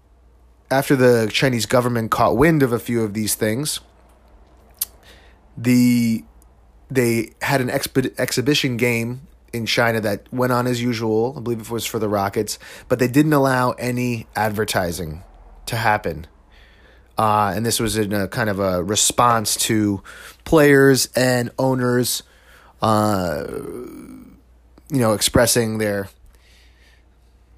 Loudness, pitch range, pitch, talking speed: -19 LUFS, 90-125 Hz, 110 Hz, 130 wpm